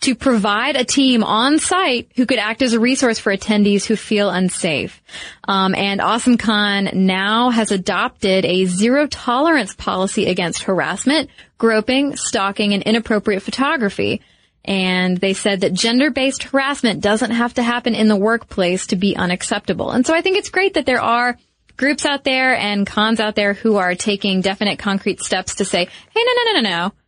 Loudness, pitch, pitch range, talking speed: -17 LUFS, 215 Hz, 200-255 Hz, 175 wpm